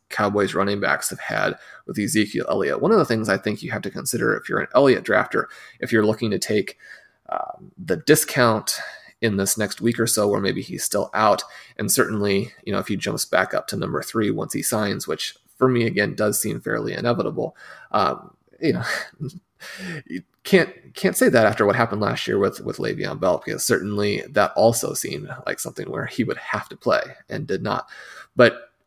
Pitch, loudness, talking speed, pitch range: 105 Hz, -22 LUFS, 205 wpm, 100-115 Hz